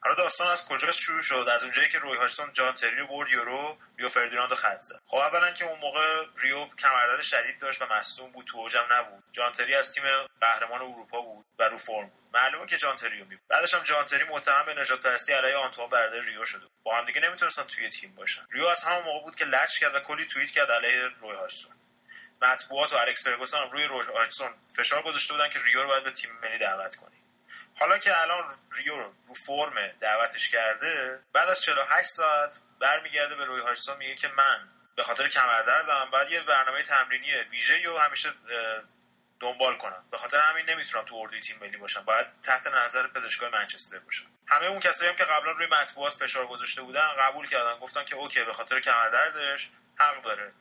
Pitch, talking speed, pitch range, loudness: 145 Hz, 205 wpm, 130-170 Hz, -26 LUFS